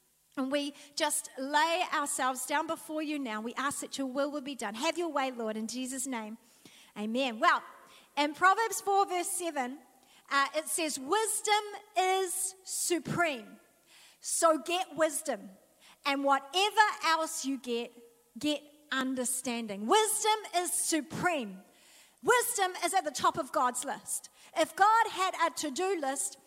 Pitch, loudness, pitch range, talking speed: 295 Hz, -31 LUFS, 265-355 Hz, 145 wpm